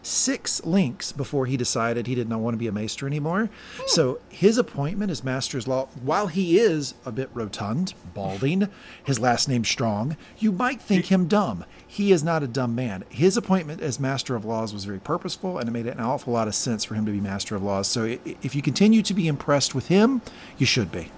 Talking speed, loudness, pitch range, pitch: 220 wpm, -24 LUFS, 115-185 Hz, 135 Hz